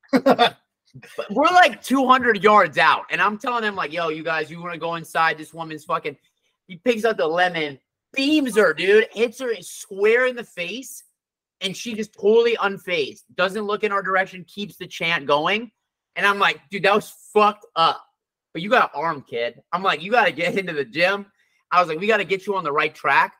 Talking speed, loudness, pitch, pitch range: 220 wpm, -20 LUFS, 200 Hz, 170-250 Hz